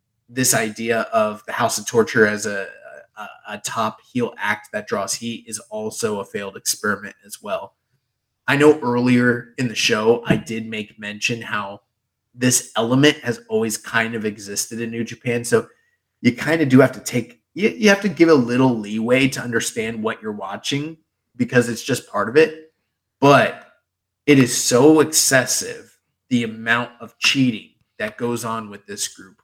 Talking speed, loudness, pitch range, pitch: 175 wpm, -19 LUFS, 115-135 Hz, 120 Hz